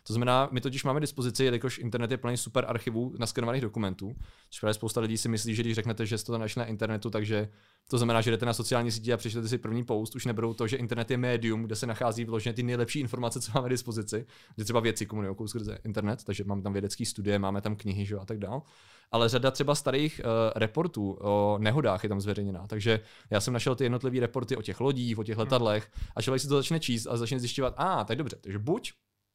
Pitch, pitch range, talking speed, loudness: 115 Hz, 110-125 Hz, 235 wpm, -30 LUFS